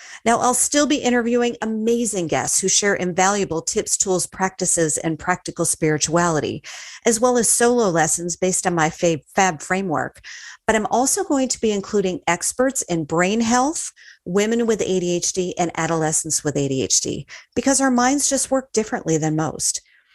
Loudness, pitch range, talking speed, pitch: -19 LUFS, 165-235 Hz, 160 wpm, 190 Hz